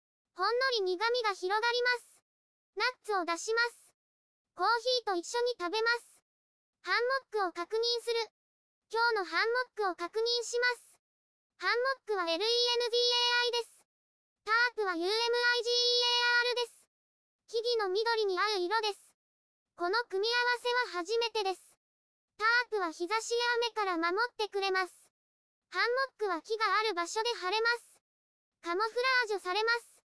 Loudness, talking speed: -31 LUFS, 300 characters per minute